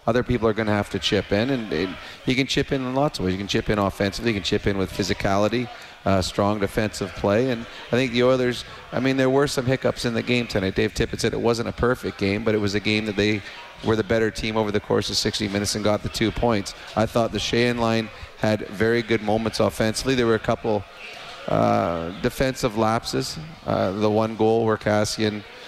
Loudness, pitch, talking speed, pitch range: -23 LUFS, 110 Hz, 240 wpm, 105-120 Hz